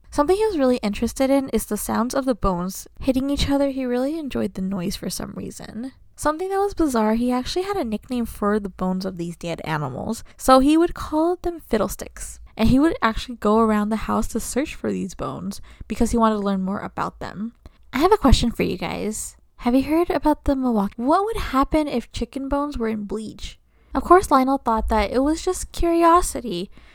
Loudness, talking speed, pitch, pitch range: -22 LUFS, 215 wpm, 245 Hz, 210-290 Hz